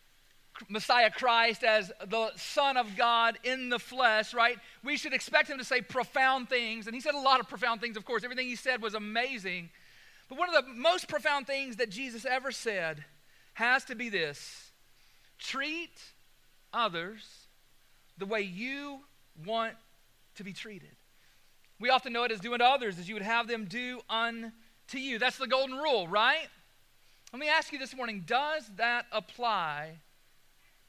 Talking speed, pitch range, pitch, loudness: 170 wpm, 210-260 Hz, 235 Hz, -30 LUFS